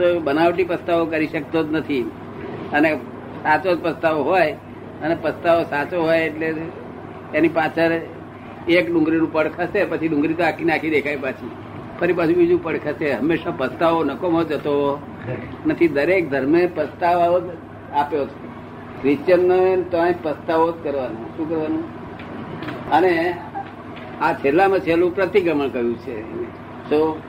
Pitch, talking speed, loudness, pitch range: 165 Hz, 135 wpm, -20 LUFS, 150-175 Hz